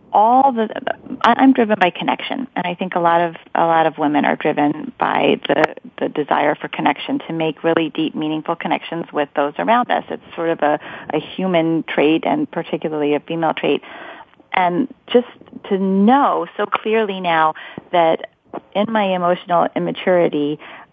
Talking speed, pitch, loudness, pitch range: 165 wpm, 175 Hz, -18 LUFS, 160-225 Hz